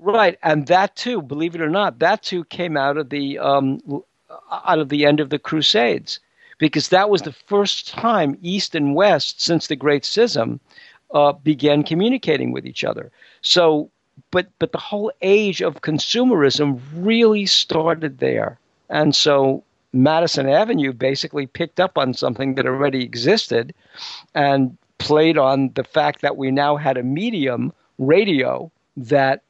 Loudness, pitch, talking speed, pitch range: -18 LUFS, 150 Hz, 155 wpm, 140-175 Hz